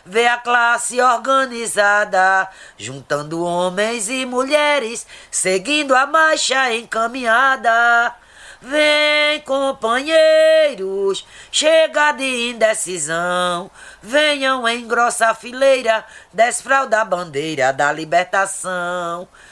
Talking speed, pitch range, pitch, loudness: 80 wpm, 190-270 Hz, 235 Hz, -16 LUFS